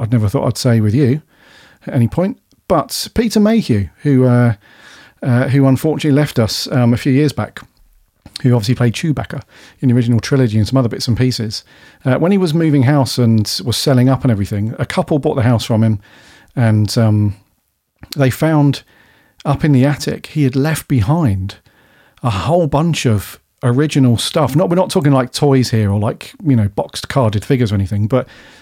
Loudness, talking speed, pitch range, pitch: -15 LUFS, 195 wpm, 115-145 Hz, 130 Hz